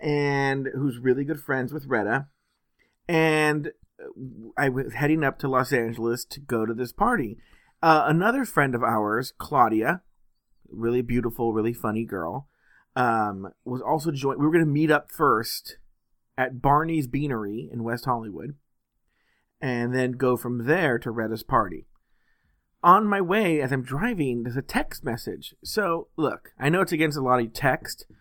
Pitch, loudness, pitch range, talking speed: 130 Hz, -25 LUFS, 120-145 Hz, 160 wpm